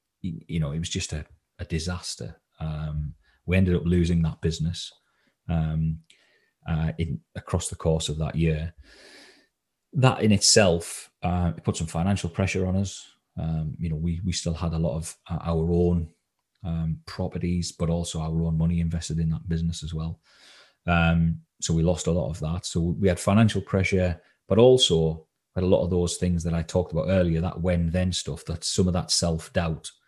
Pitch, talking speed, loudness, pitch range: 85 Hz, 190 wpm, -25 LUFS, 80-90 Hz